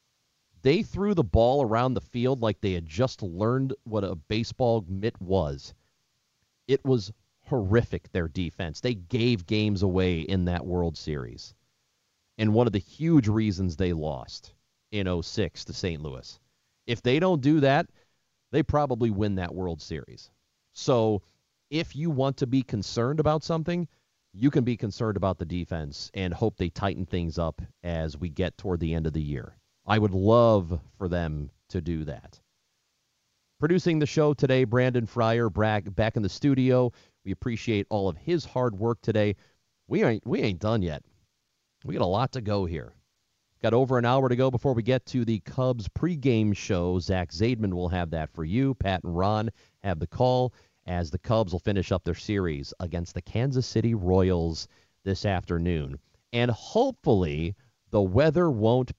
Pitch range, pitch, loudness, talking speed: 90-125 Hz, 105 Hz, -27 LUFS, 175 wpm